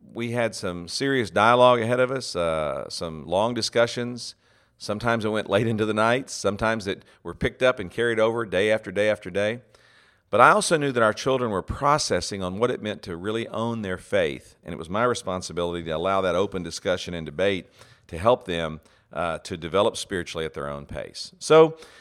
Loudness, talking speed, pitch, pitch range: -24 LUFS, 200 wpm, 110 Hz, 95-125 Hz